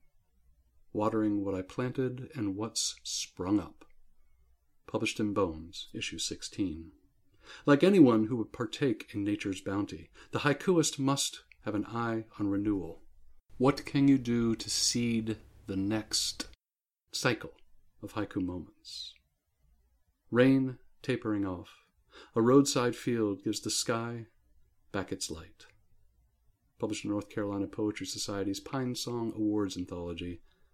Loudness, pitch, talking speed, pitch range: -31 LUFS, 105 Hz, 125 wpm, 90-120 Hz